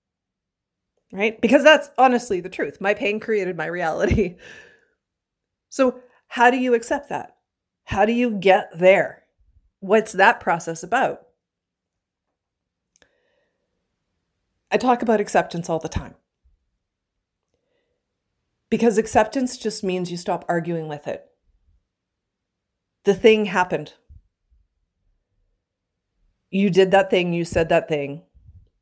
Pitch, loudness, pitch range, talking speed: 190 Hz, -20 LUFS, 140-235 Hz, 110 wpm